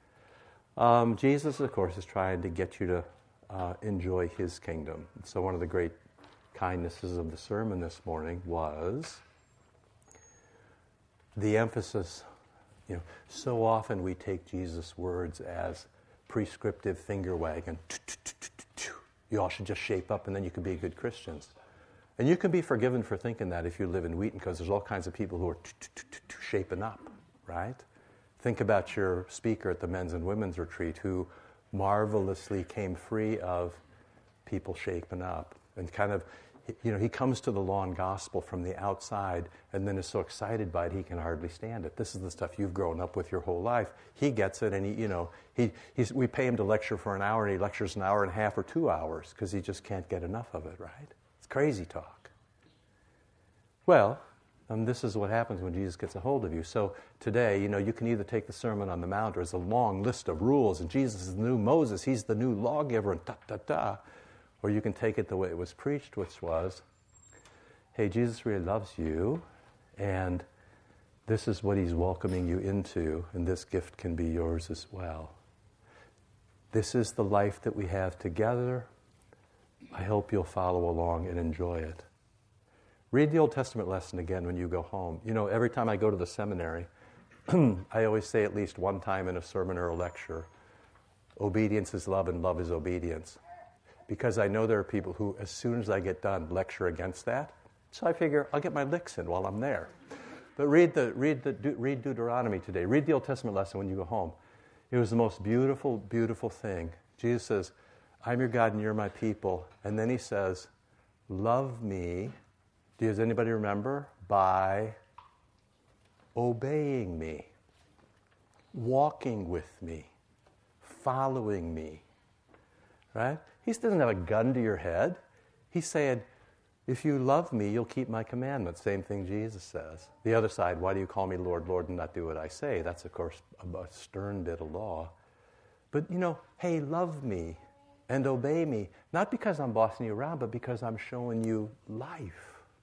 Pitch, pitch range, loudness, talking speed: 100 Hz, 90-115 Hz, -33 LUFS, 190 wpm